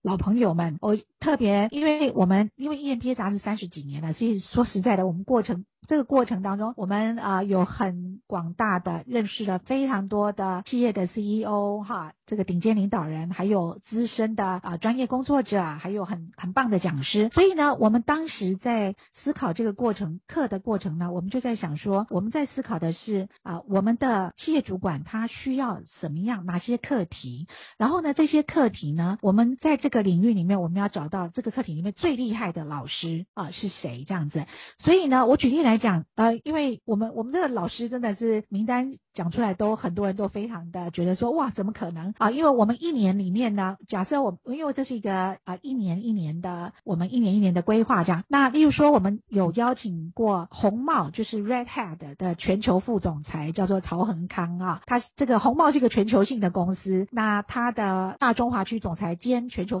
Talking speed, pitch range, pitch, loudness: 325 characters per minute, 185-245 Hz, 210 Hz, -25 LUFS